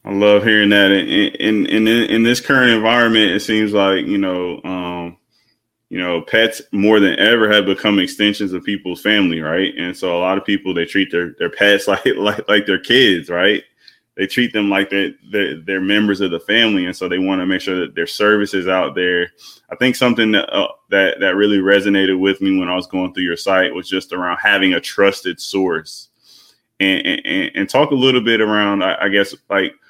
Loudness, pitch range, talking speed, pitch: -15 LUFS, 95-110 Hz, 215 wpm, 100 Hz